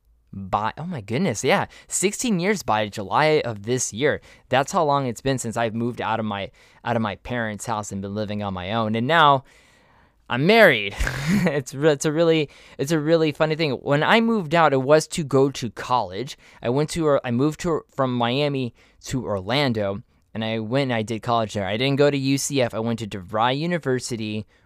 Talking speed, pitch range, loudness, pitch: 205 wpm, 110-150 Hz, -22 LUFS, 125 Hz